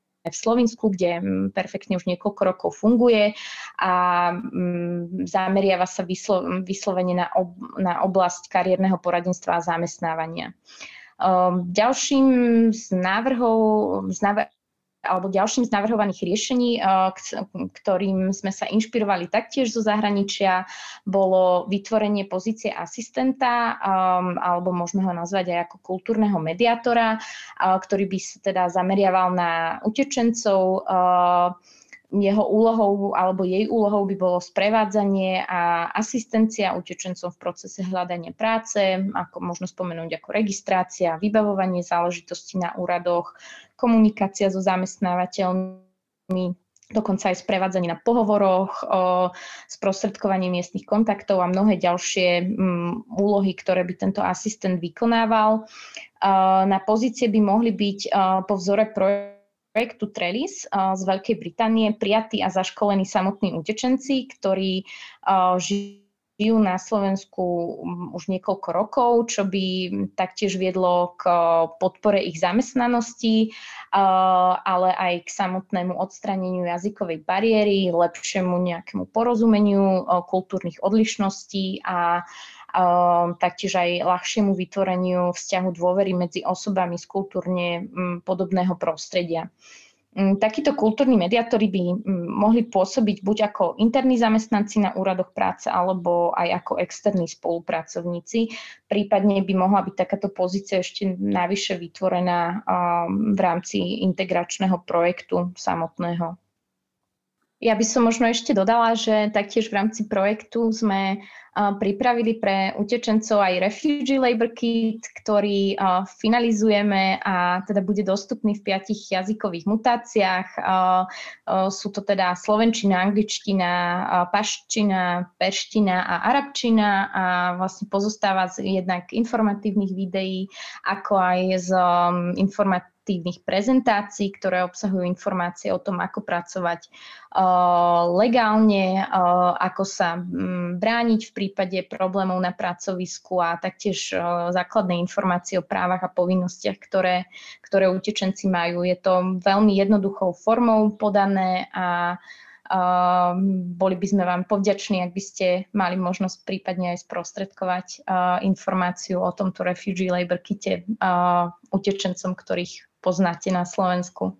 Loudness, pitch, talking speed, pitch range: -22 LUFS, 190 Hz, 110 wpm, 180-210 Hz